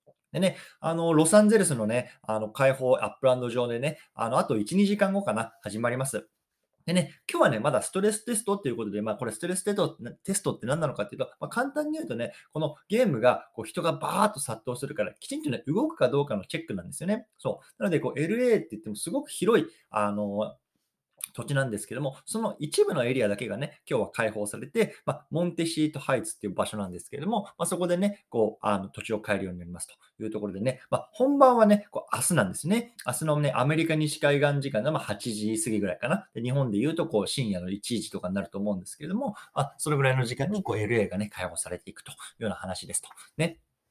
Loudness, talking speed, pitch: -28 LUFS, 470 characters per minute, 140 Hz